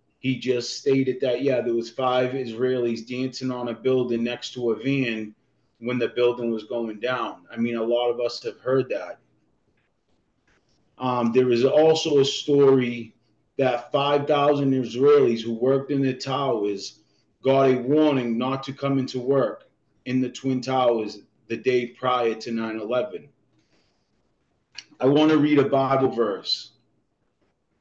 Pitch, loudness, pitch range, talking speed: 125 Hz, -23 LUFS, 120-135 Hz, 150 wpm